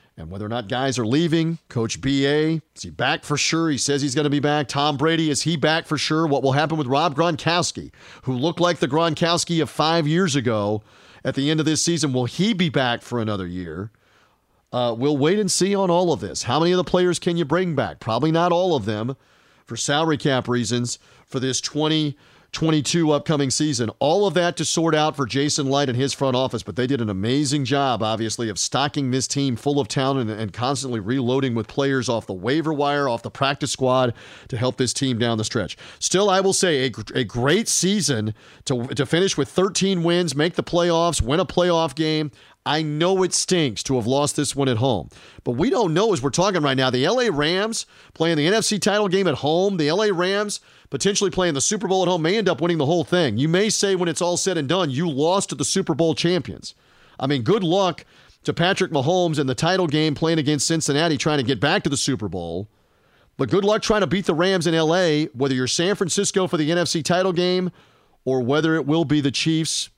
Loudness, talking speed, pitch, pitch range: -21 LUFS, 230 wpm, 150 Hz, 130-170 Hz